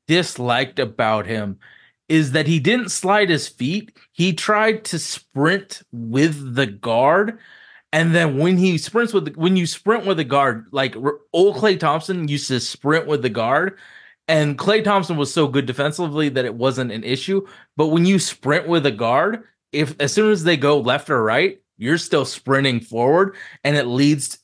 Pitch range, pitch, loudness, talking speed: 135-185 Hz, 155 Hz, -19 LUFS, 185 wpm